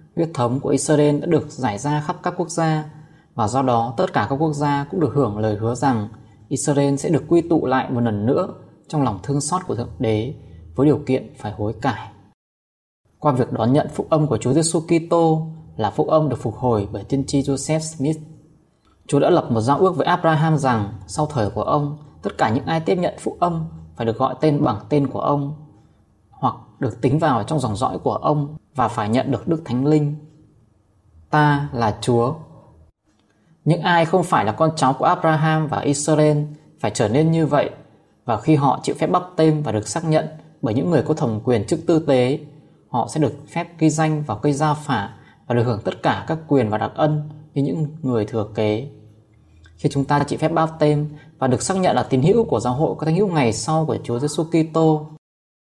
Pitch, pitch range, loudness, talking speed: 145 Hz, 120-155 Hz, -20 LUFS, 220 wpm